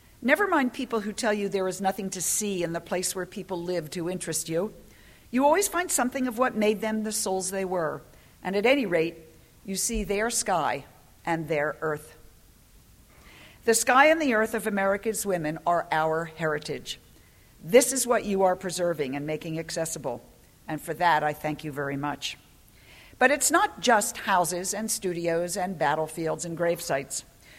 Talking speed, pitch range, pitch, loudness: 180 wpm, 160-220 Hz, 185 Hz, -26 LUFS